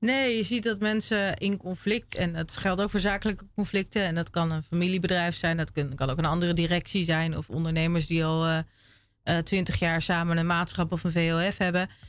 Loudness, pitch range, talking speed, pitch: -27 LUFS, 165-195 Hz, 220 wpm, 175 Hz